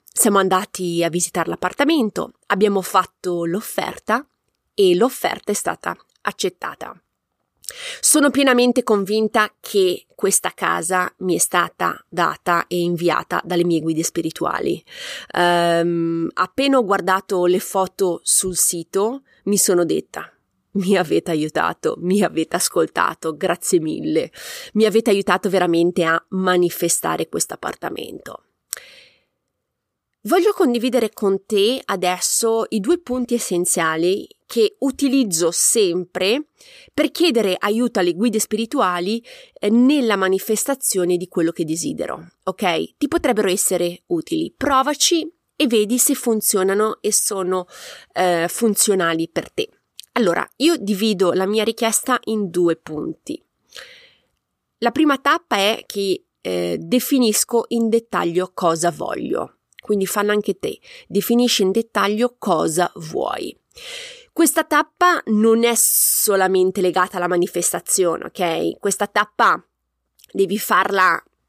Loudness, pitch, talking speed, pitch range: -19 LUFS, 205 Hz, 115 wpm, 180-255 Hz